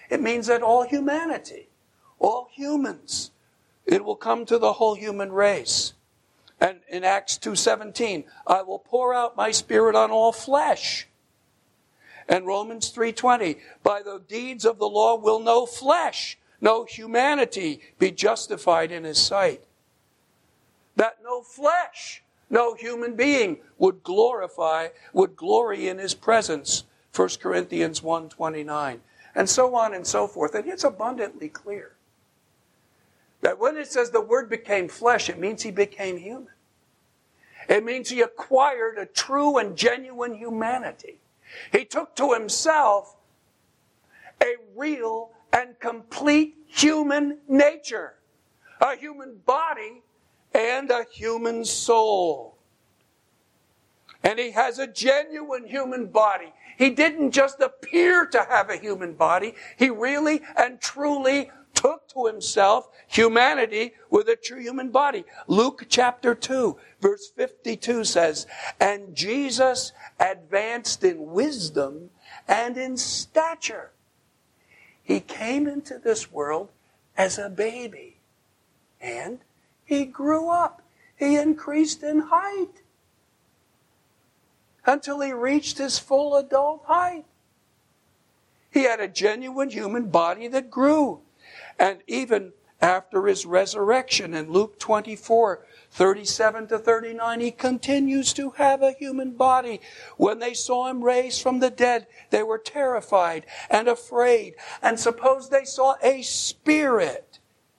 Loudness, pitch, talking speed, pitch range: -23 LUFS, 245 Hz, 125 wpm, 215-280 Hz